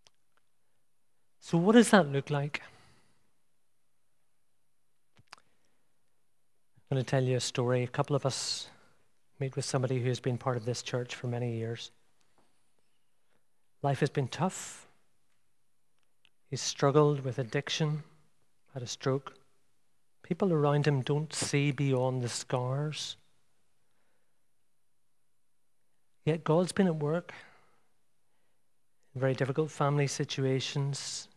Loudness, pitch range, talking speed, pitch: -31 LUFS, 130-150 Hz, 110 wpm, 140 Hz